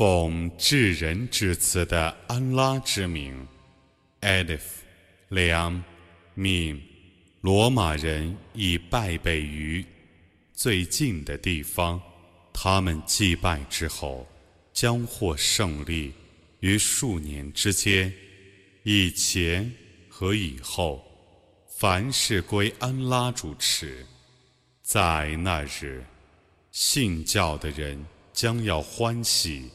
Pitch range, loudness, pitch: 80-100 Hz, -25 LUFS, 90 Hz